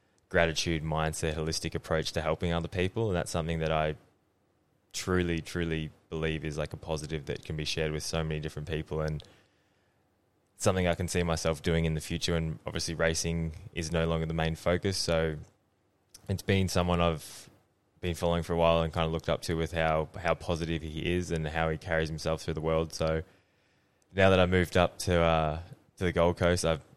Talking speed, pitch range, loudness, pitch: 200 wpm, 80-90 Hz, -30 LUFS, 85 Hz